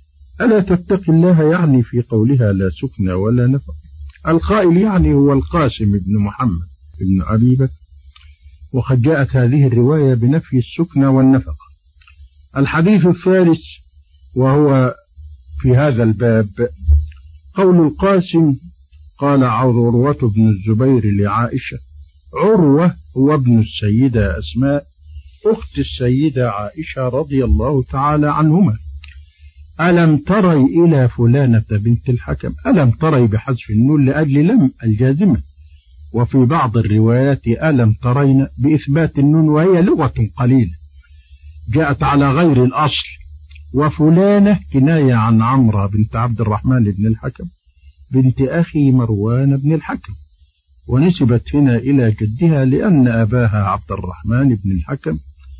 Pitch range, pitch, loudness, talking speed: 95-145 Hz, 125 Hz, -14 LUFS, 110 wpm